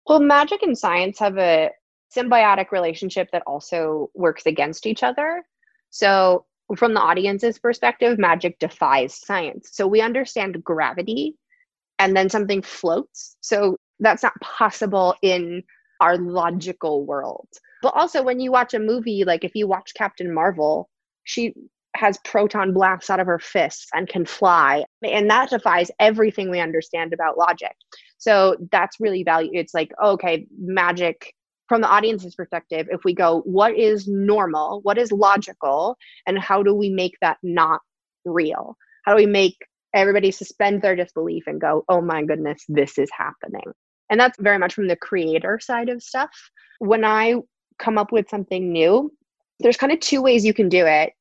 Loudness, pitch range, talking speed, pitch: -20 LUFS, 175-220 Hz, 165 wpm, 195 Hz